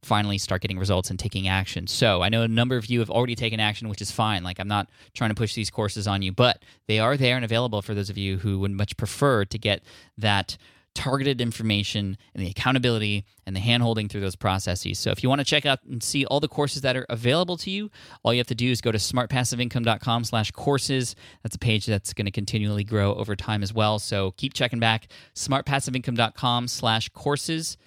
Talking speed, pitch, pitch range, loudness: 230 wpm, 110 Hz, 100-125 Hz, -25 LUFS